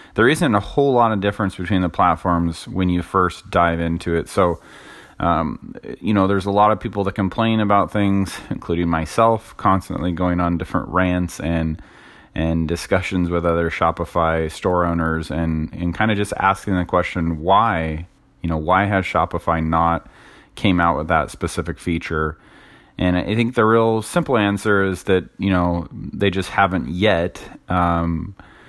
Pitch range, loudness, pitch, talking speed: 85-100 Hz, -19 LUFS, 90 Hz, 170 wpm